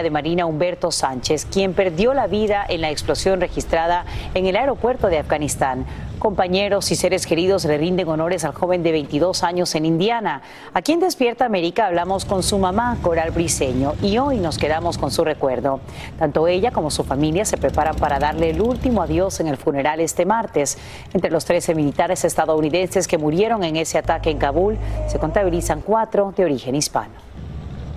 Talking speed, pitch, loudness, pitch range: 180 wpm, 170 Hz, -20 LUFS, 155-190 Hz